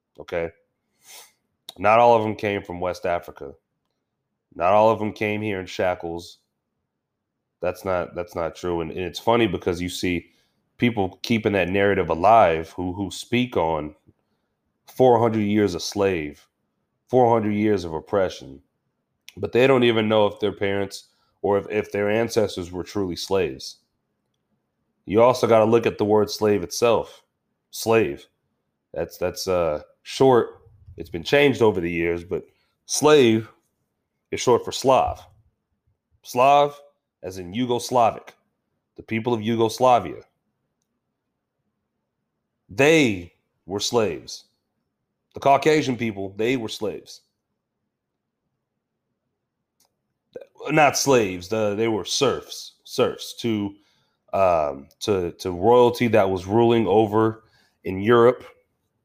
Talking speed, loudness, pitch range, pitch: 130 wpm, -21 LUFS, 90-115 Hz, 105 Hz